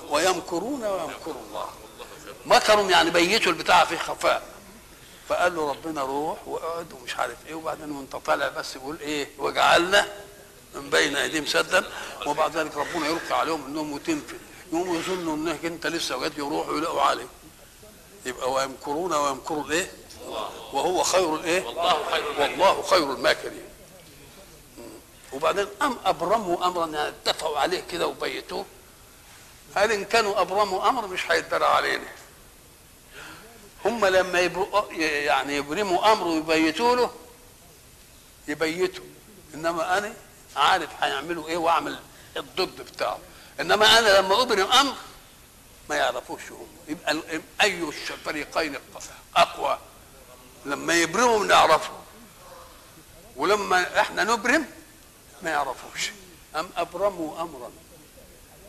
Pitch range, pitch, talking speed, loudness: 160-210 Hz, 175 Hz, 115 wpm, -24 LUFS